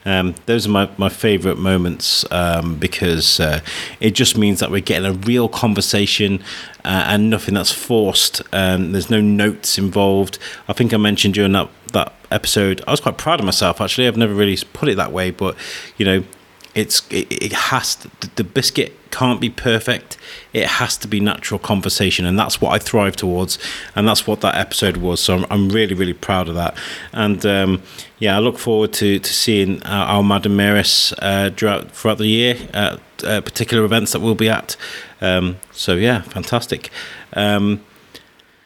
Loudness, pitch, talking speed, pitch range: -17 LUFS, 100 Hz, 190 wpm, 95-110 Hz